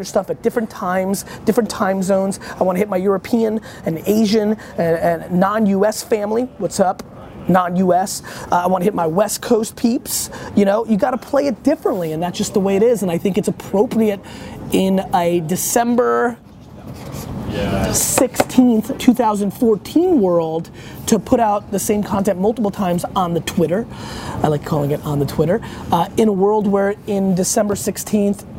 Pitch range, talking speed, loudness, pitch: 185-220 Hz, 180 wpm, -18 LUFS, 200 Hz